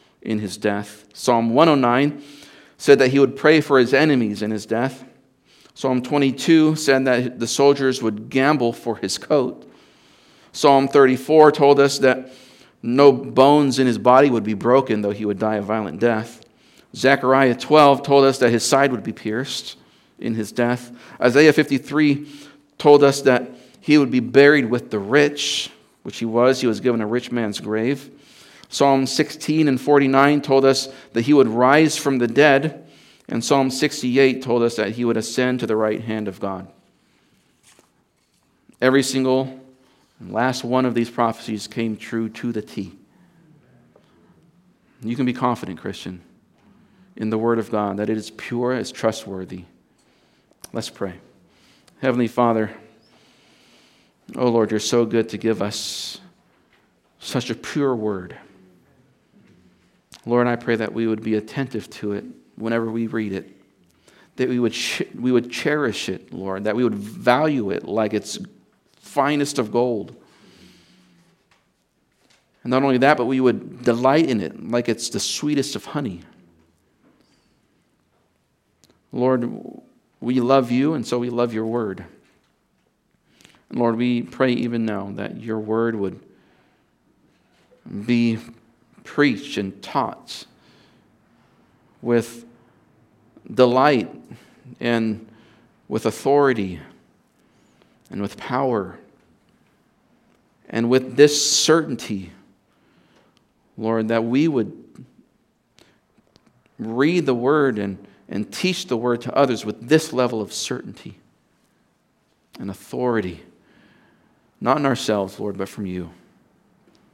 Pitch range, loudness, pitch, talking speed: 110-135 Hz, -19 LUFS, 120 Hz, 140 wpm